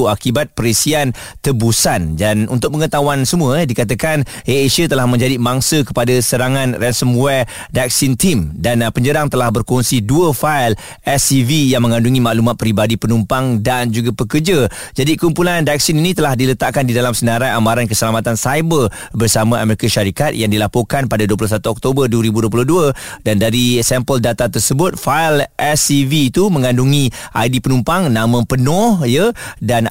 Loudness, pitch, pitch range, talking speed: -14 LUFS, 125 Hz, 115-145 Hz, 140 wpm